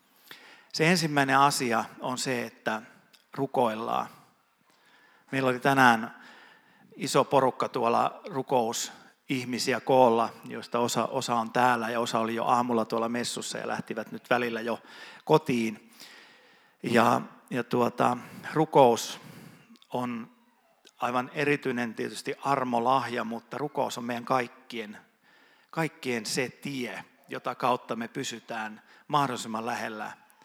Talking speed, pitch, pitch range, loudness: 110 wpm, 125 Hz, 115-140 Hz, -28 LUFS